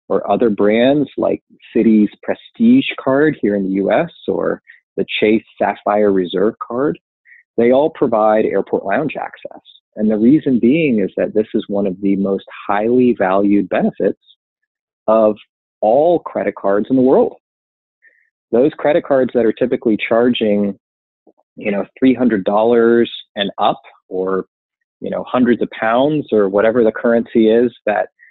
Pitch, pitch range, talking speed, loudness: 110 Hz, 100-125 Hz, 145 wpm, -15 LUFS